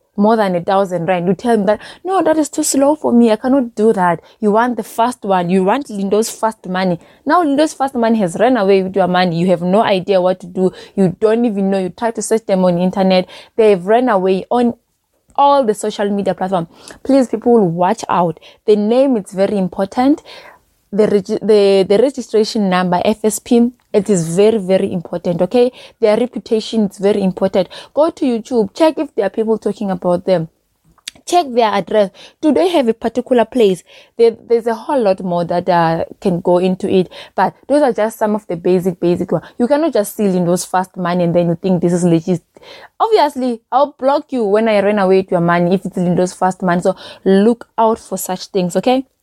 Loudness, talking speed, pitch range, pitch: -15 LUFS, 215 wpm, 185-235 Hz, 210 Hz